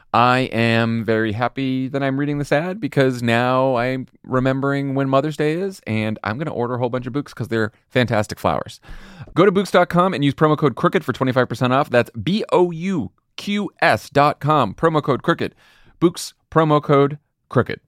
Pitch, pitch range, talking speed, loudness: 135 Hz, 120-150 Hz, 190 wpm, -19 LUFS